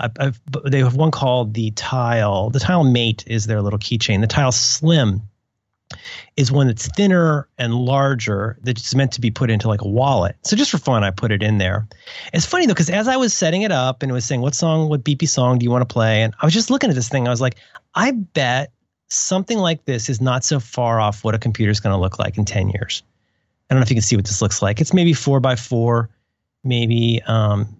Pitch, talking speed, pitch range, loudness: 125 Hz, 250 wpm, 110-140 Hz, -18 LUFS